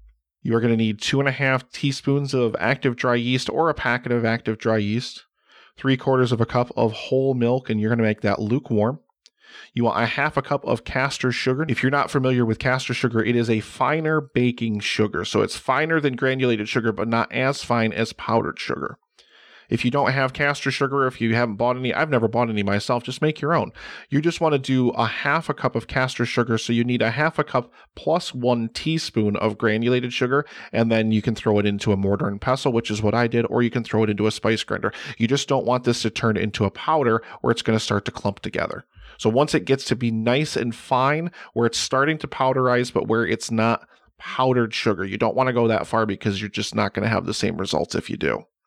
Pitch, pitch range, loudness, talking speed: 120 Hz, 110-135 Hz, -22 LUFS, 245 wpm